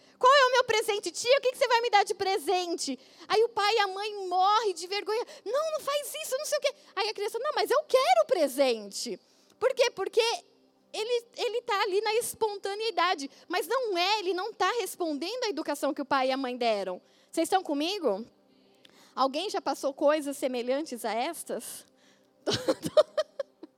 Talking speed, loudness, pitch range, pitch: 190 wpm, -28 LUFS, 290-430 Hz, 370 Hz